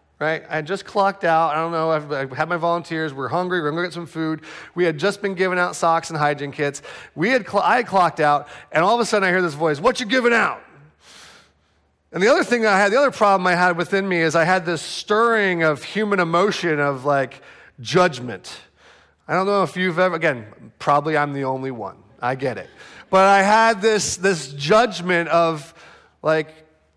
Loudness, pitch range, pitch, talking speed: -19 LUFS, 155-195 Hz, 170 Hz, 220 wpm